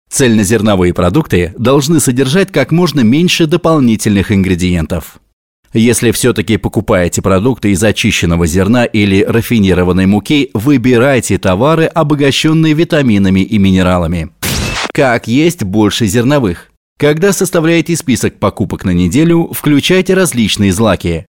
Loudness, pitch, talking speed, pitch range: -10 LUFS, 115 Hz, 105 wpm, 95-150 Hz